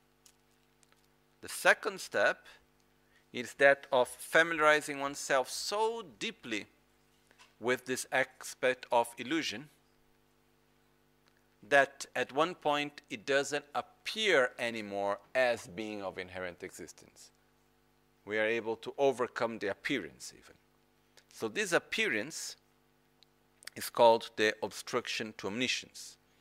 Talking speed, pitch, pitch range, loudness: 100 wpm, 120 Hz, 100-140 Hz, -32 LUFS